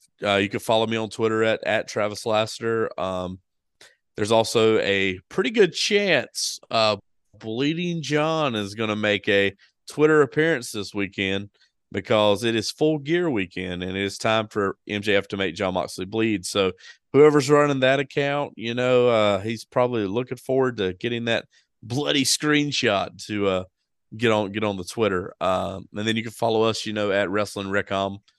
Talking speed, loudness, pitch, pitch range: 180 wpm, -23 LUFS, 110 Hz, 100-125 Hz